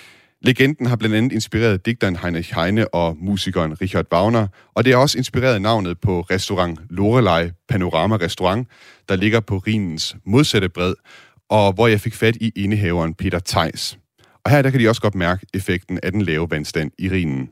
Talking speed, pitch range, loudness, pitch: 180 wpm, 90-115 Hz, -19 LUFS, 100 Hz